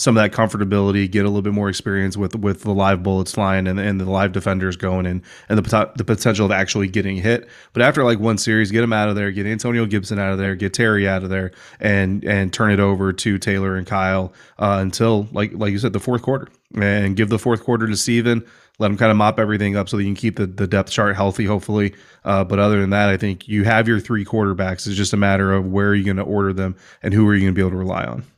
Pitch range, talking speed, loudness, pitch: 95-110 Hz, 275 wpm, -19 LUFS, 100 Hz